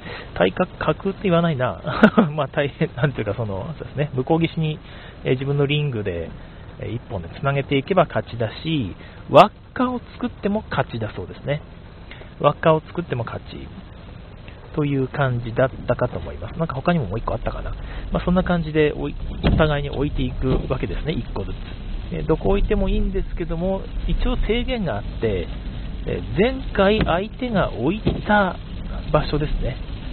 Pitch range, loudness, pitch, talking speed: 105-170 Hz, -22 LUFS, 140 Hz, 305 characters per minute